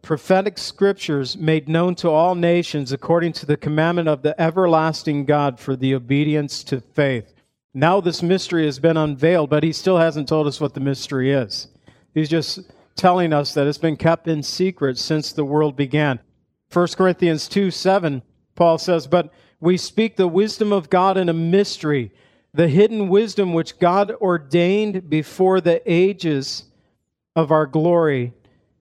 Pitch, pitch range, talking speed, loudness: 160 Hz, 145-180 Hz, 160 wpm, -19 LUFS